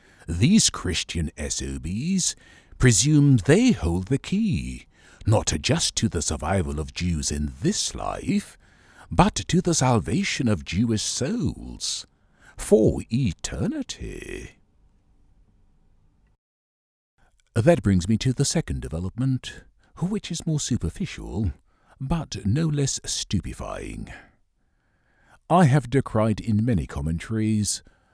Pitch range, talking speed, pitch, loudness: 85-140 Hz, 100 wpm, 110 Hz, -24 LUFS